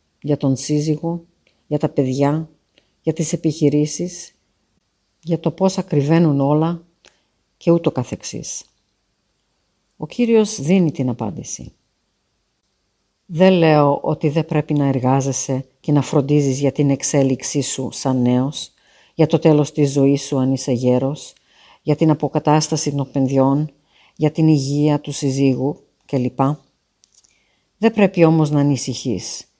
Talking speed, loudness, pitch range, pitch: 130 wpm, -18 LUFS, 135-160 Hz, 145 Hz